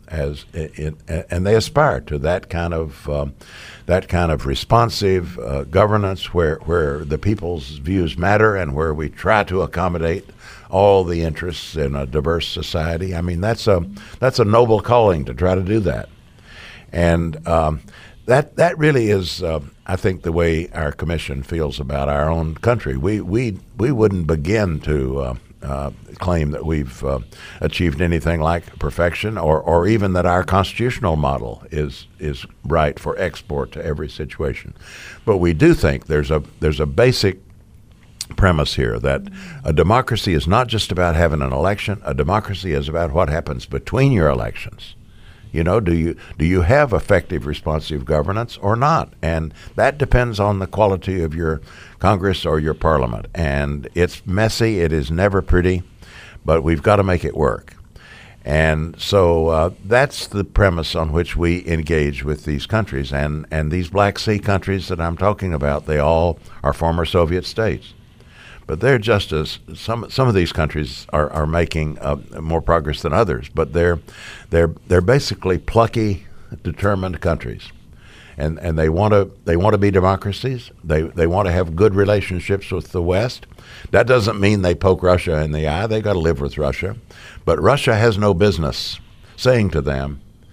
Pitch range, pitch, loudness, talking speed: 80-100 Hz, 85 Hz, -19 LUFS, 175 wpm